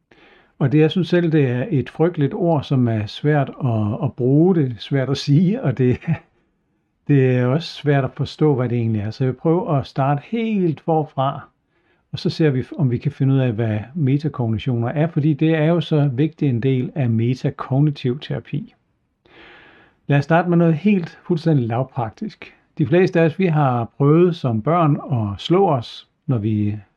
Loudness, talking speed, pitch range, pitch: -19 LUFS, 190 wpm, 125-160 Hz, 145 Hz